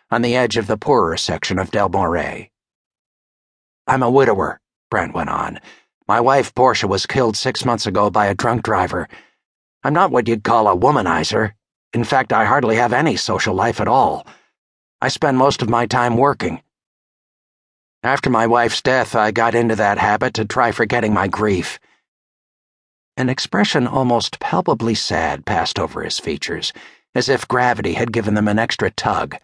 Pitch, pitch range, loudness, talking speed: 115 Hz, 105-125 Hz, -17 LUFS, 170 wpm